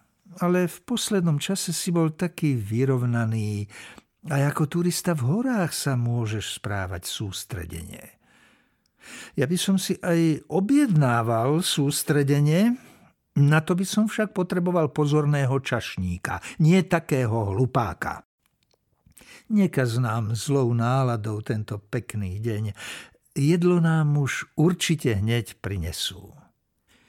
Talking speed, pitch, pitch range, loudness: 110 wpm, 145 Hz, 115-175 Hz, -24 LUFS